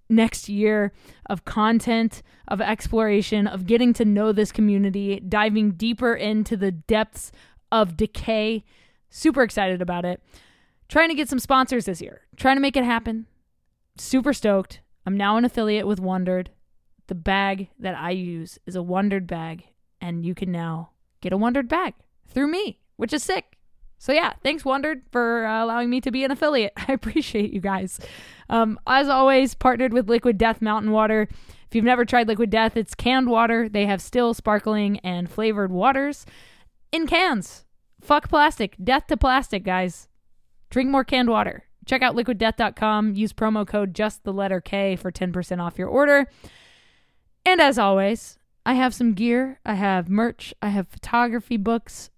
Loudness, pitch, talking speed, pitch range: -22 LUFS, 220 Hz, 170 wpm, 200-250 Hz